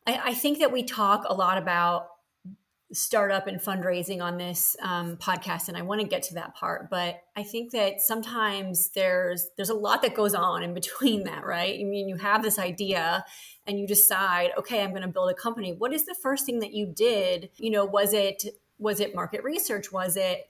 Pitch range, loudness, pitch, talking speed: 180-220 Hz, -26 LUFS, 200 Hz, 215 wpm